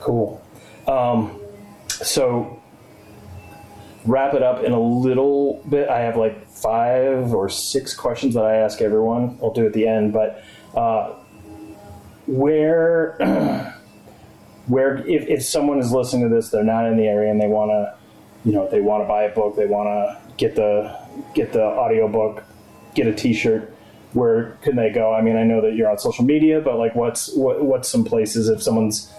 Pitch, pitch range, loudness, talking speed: 110 Hz, 105-120 Hz, -19 LUFS, 180 wpm